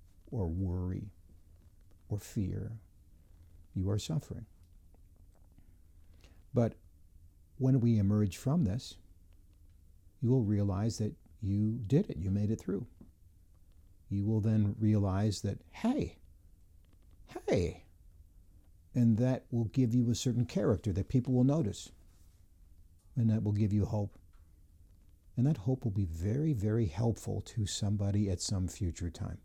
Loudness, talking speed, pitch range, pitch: -33 LUFS, 130 wpm, 85-110 Hz, 95 Hz